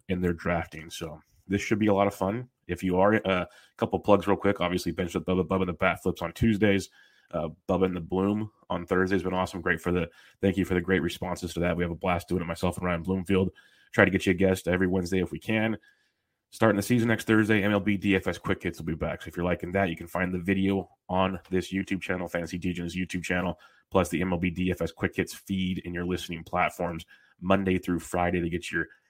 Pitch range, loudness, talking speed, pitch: 90-95 Hz, -28 LUFS, 245 wpm, 90 Hz